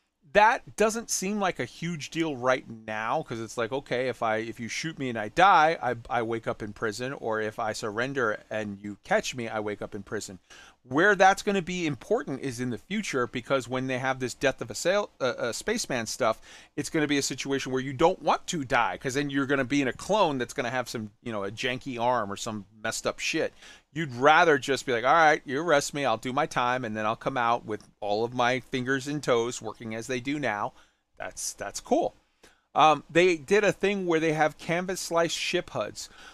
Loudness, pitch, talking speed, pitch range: -27 LUFS, 130 Hz, 240 wpm, 115-155 Hz